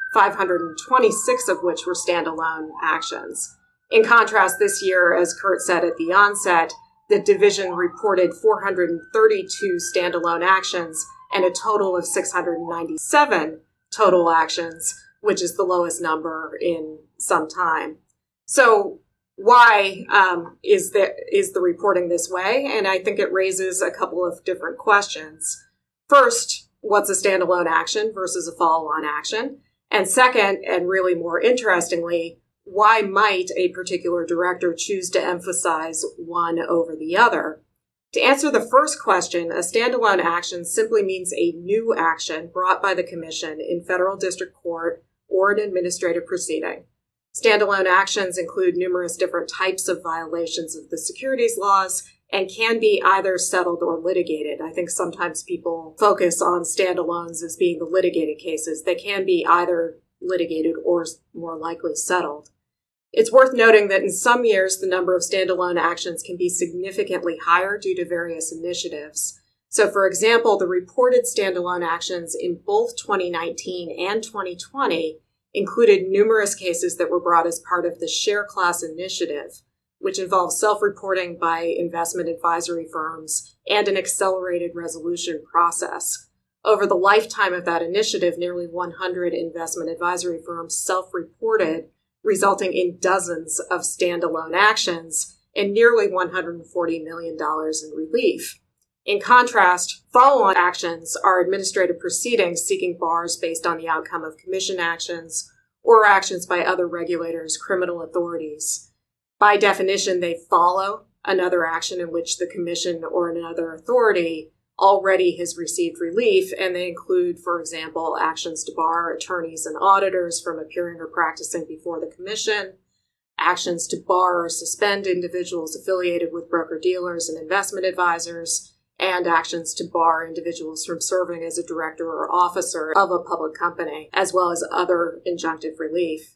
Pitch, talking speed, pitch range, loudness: 180 Hz, 145 wpm, 170-200 Hz, -20 LUFS